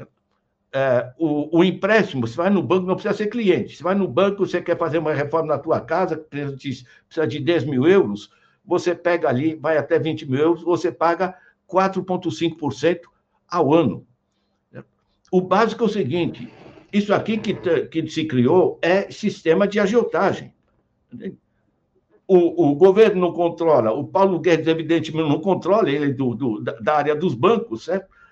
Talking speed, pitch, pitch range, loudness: 160 wpm, 170 Hz, 155-185 Hz, -20 LUFS